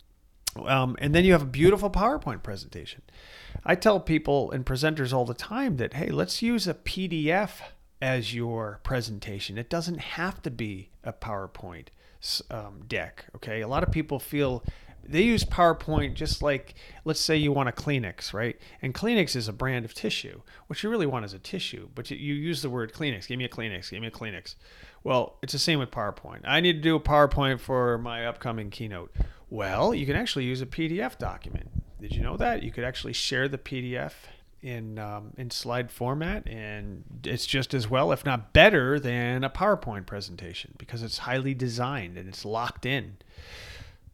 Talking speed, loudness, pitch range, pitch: 190 wpm, -28 LUFS, 110-145 Hz, 125 Hz